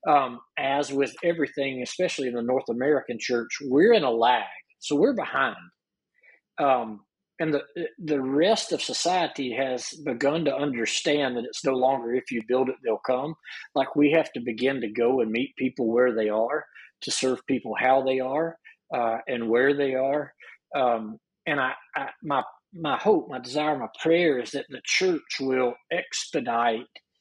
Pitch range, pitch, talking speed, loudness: 120-145 Hz, 130 Hz, 175 wpm, -26 LUFS